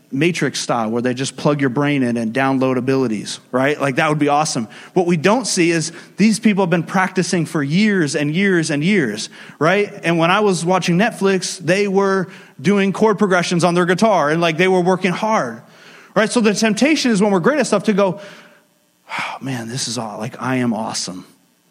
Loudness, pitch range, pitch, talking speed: -17 LUFS, 145-200 Hz, 180 Hz, 210 wpm